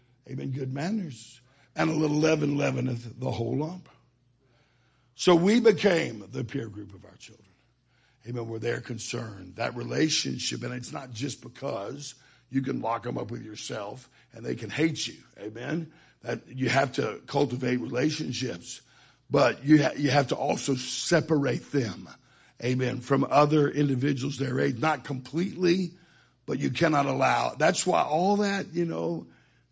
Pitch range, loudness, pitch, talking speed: 120-150 Hz, -27 LUFS, 135 Hz, 155 wpm